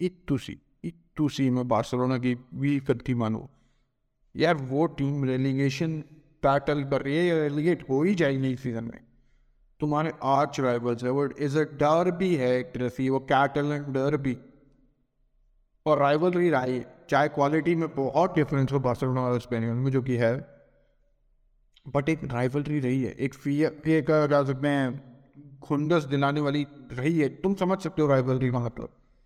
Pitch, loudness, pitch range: 140 Hz, -26 LUFS, 130-150 Hz